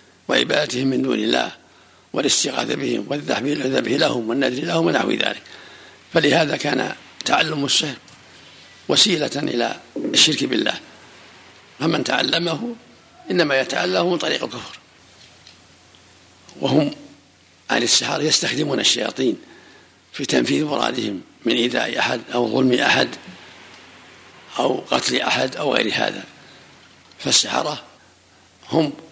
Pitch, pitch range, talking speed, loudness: 130 Hz, 90-150 Hz, 100 wpm, -19 LUFS